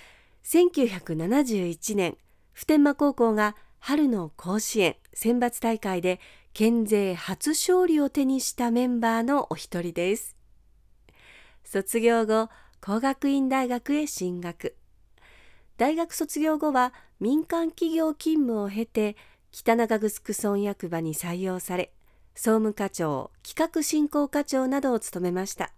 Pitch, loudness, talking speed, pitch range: 230 Hz, -26 LUFS, 215 characters per minute, 190-285 Hz